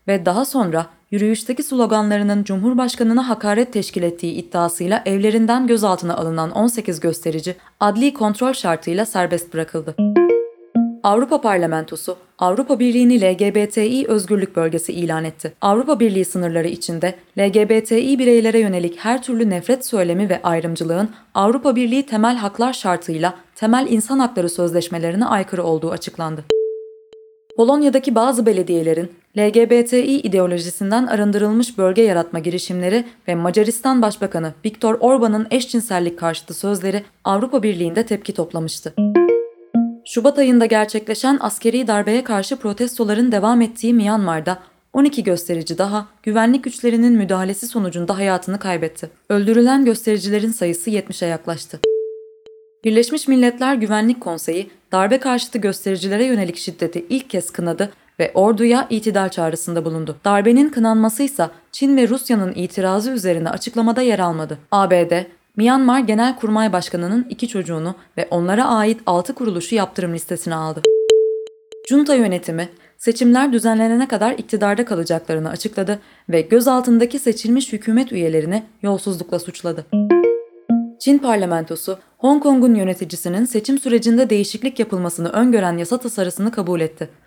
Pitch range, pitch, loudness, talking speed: 175-235 Hz, 210 Hz, -18 LUFS, 115 wpm